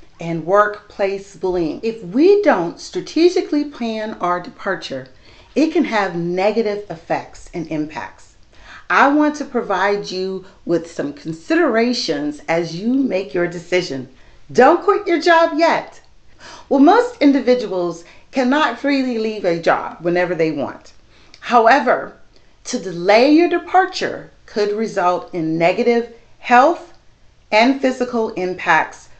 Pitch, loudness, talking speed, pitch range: 215 Hz, -17 LUFS, 120 wpm, 175-280 Hz